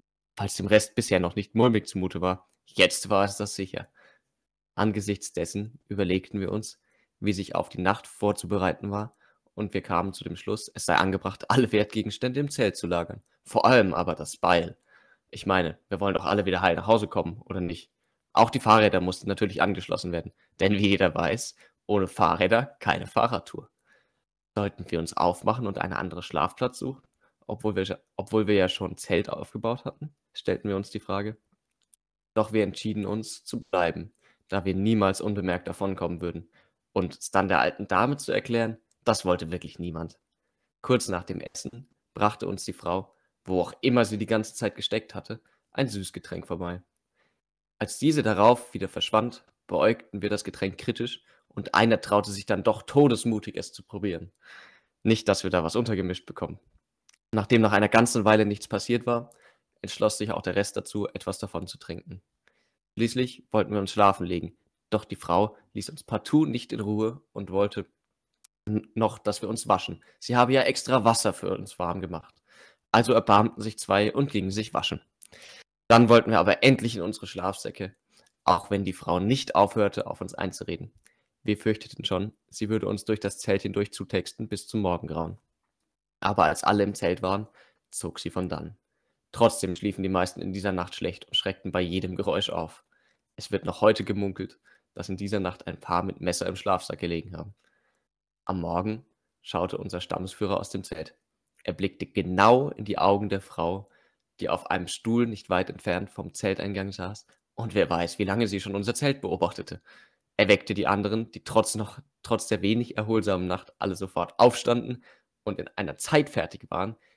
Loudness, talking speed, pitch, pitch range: -27 LUFS, 180 wpm, 100 Hz, 95-110 Hz